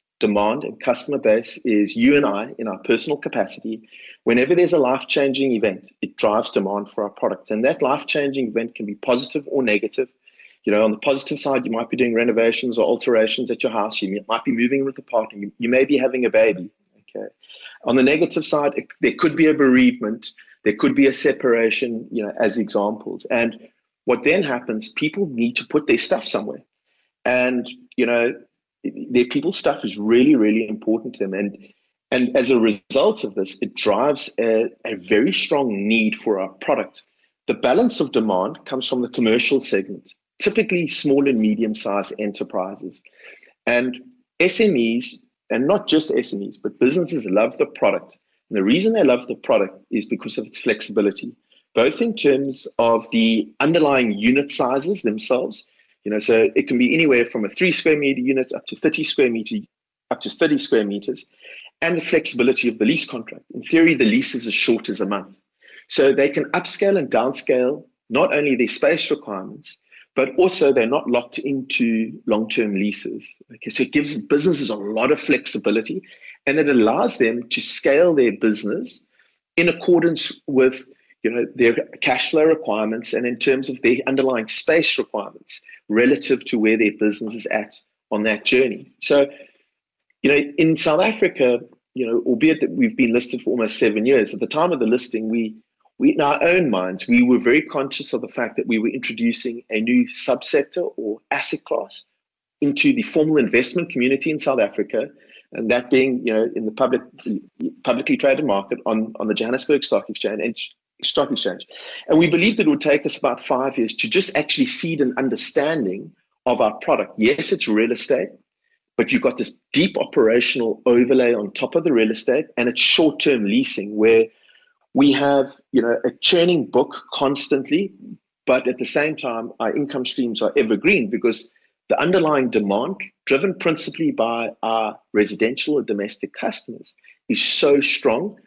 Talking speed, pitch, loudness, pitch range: 180 wpm, 130 Hz, -19 LUFS, 115-165 Hz